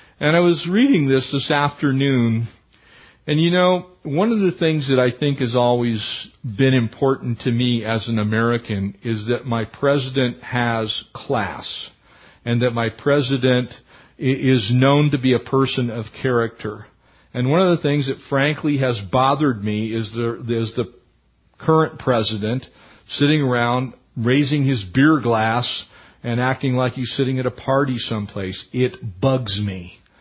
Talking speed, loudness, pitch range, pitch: 155 wpm, -20 LUFS, 115-140 Hz, 125 Hz